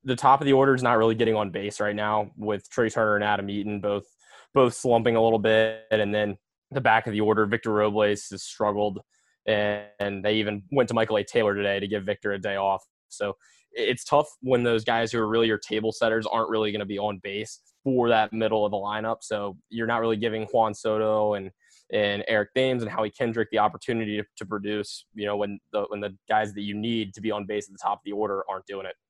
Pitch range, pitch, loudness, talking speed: 105-115 Hz, 105 Hz, -25 LUFS, 245 wpm